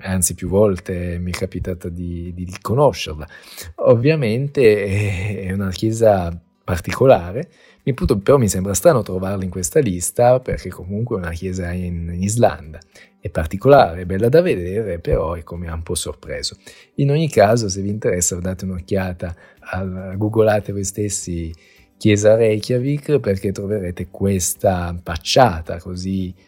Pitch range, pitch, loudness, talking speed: 90-105 Hz, 95 Hz, -19 LUFS, 140 wpm